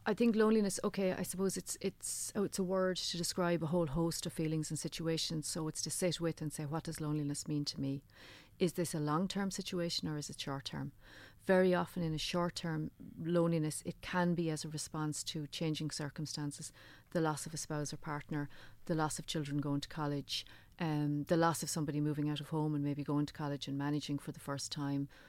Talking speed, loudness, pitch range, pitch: 230 wpm, -37 LUFS, 145-175 Hz, 155 Hz